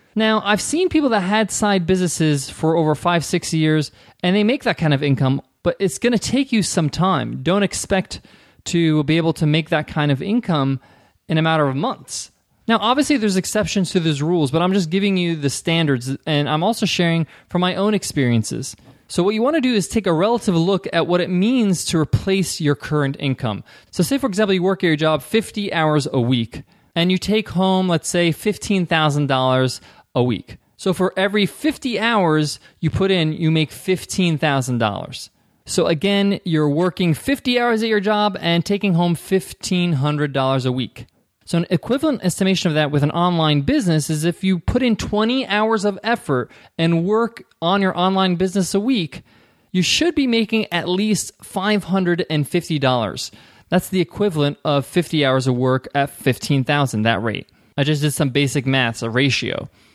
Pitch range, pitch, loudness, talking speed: 145-200 Hz, 175 Hz, -19 LUFS, 195 wpm